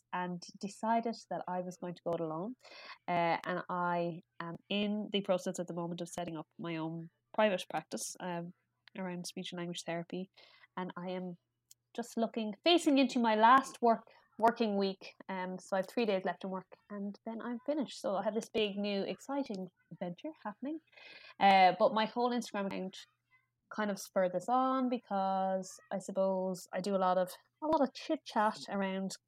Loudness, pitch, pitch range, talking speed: -35 LUFS, 195 Hz, 180-225 Hz, 190 wpm